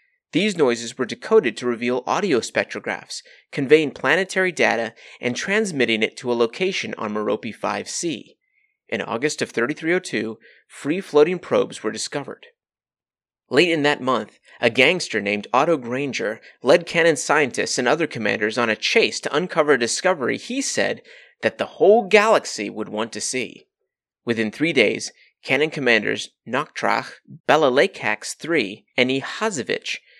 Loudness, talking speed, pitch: -21 LUFS, 140 wpm, 155 Hz